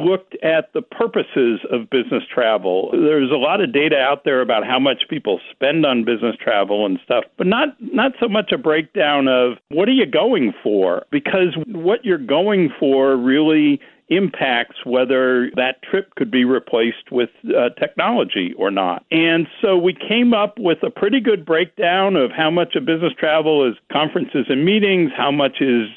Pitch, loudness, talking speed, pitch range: 155 Hz, -17 LUFS, 180 wpm, 130-190 Hz